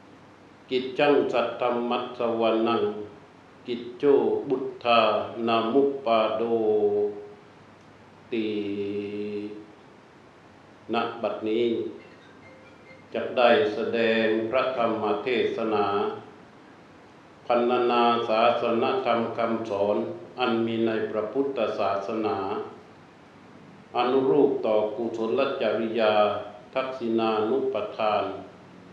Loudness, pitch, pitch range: -25 LUFS, 115 Hz, 105-120 Hz